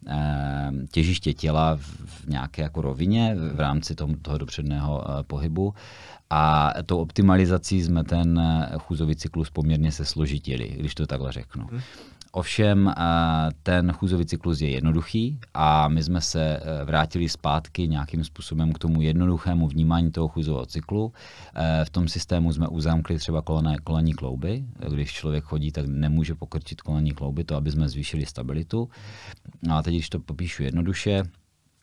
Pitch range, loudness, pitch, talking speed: 75-85 Hz, -25 LUFS, 80 Hz, 140 wpm